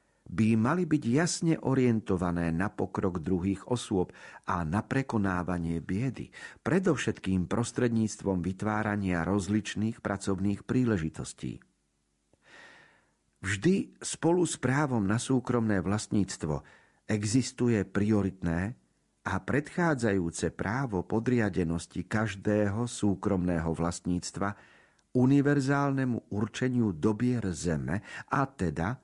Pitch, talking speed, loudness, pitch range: 105 Hz, 85 wpm, -30 LUFS, 95-125 Hz